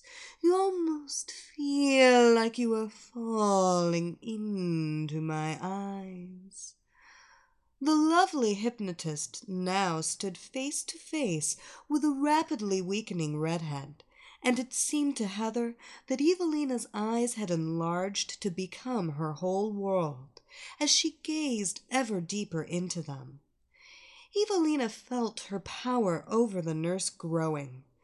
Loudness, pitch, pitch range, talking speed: -30 LUFS, 215 Hz, 175-290 Hz, 115 wpm